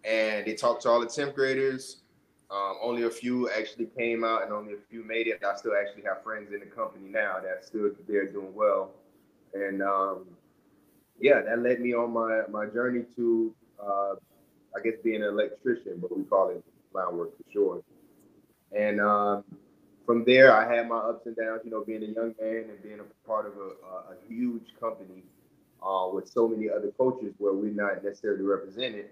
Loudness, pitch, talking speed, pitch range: -28 LUFS, 110 Hz, 200 wpm, 100-120 Hz